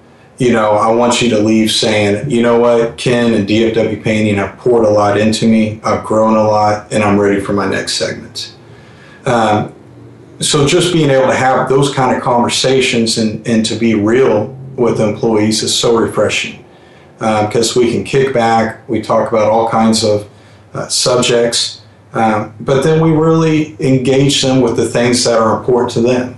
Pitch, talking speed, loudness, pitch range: 115 Hz, 185 wpm, -12 LUFS, 110-125 Hz